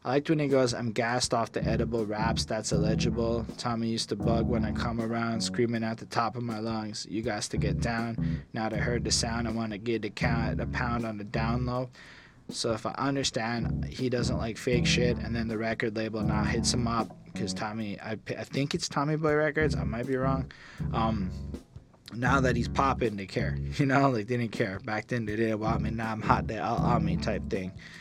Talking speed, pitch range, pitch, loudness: 235 wpm, 110-125 Hz, 115 Hz, -29 LUFS